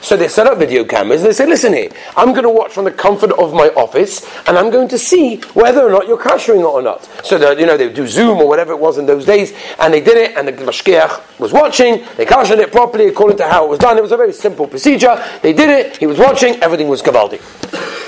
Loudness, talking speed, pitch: -11 LUFS, 270 wpm, 240 Hz